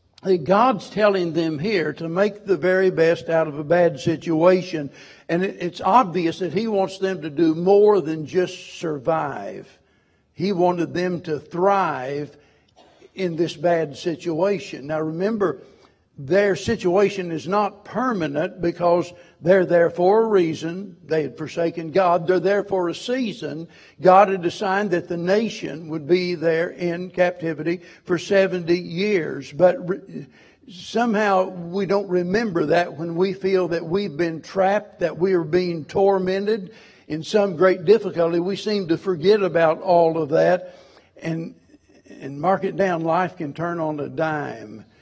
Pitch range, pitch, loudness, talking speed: 165-195 Hz, 180 Hz, -21 LUFS, 150 wpm